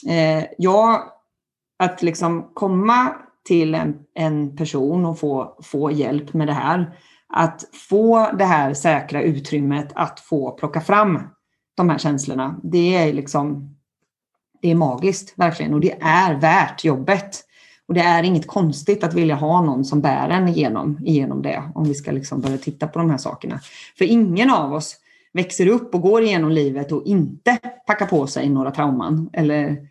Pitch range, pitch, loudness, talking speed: 145-185 Hz, 160 Hz, -19 LUFS, 165 wpm